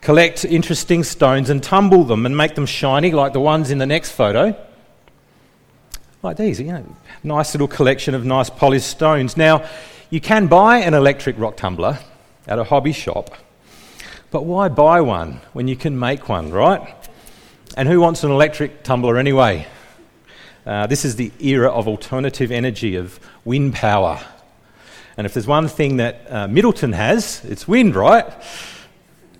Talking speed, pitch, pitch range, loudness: 165 wpm, 140 Hz, 125-155 Hz, -16 LUFS